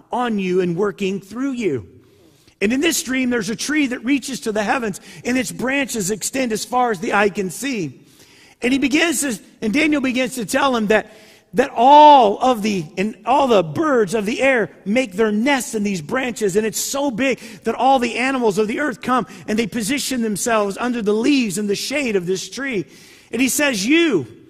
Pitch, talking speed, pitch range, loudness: 235 Hz, 210 wpm, 210-265 Hz, -18 LUFS